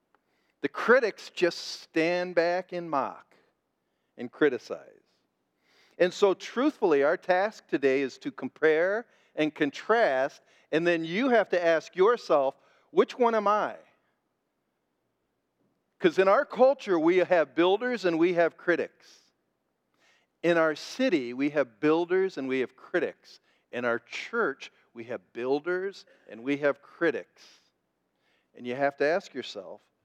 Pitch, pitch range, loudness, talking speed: 175 Hz, 145-200 Hz, -27 LUFS, 135 wpm